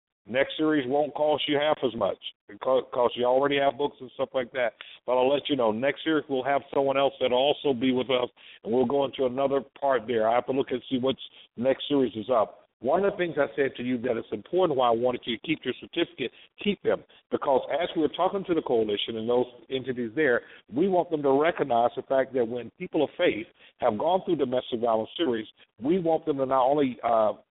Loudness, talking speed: -27 LUFS, 240 wpm